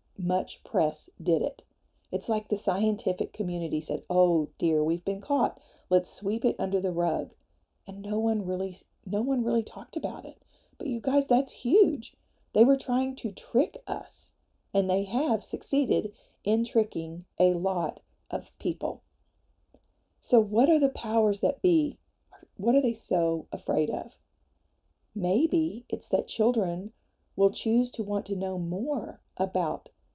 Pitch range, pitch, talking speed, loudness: 185-245 Hz, 210 Hz, 155 wpm, -28 LUFS